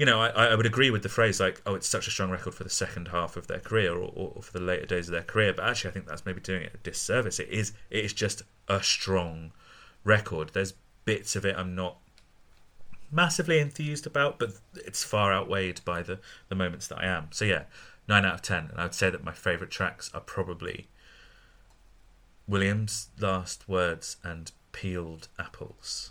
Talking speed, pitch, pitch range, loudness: 210 wpm, 95 Hz, 90-110 Hz, -29 LUFS